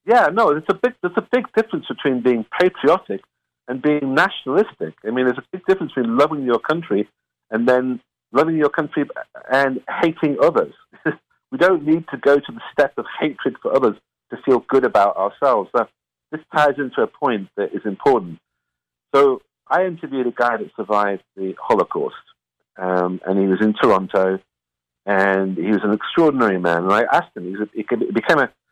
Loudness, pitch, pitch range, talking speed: -19 LUFS, 140 Hz, 105-170 Hz, 180 wpm